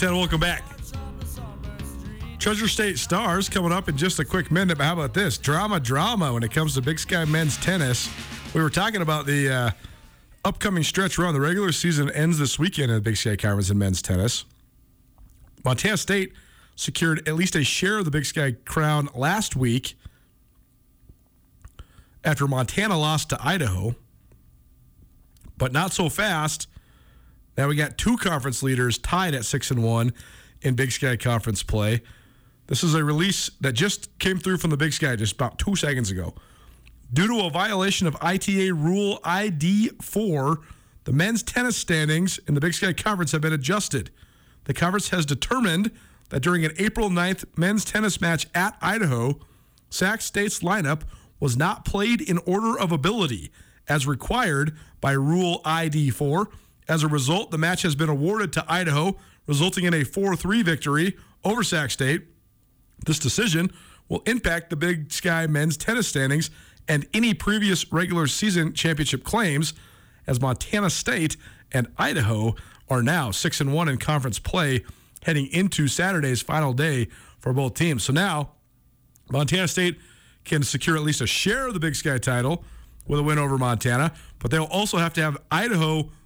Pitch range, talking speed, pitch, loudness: 130-180 Hz, 165 wpm, 155 Hz, -23 LUFS